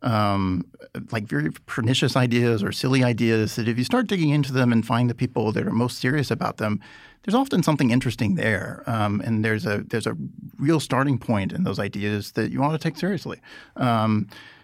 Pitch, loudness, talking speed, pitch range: 120 Hz, -23 LUFS, 200 wpm, 105-135 Hz